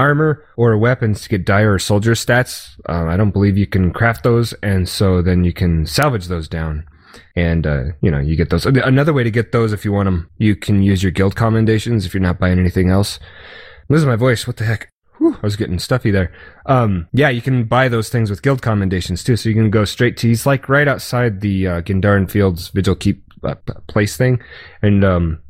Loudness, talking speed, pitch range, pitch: -16 LUFS, 230 wpm, 90-120 Hz, 105 Hz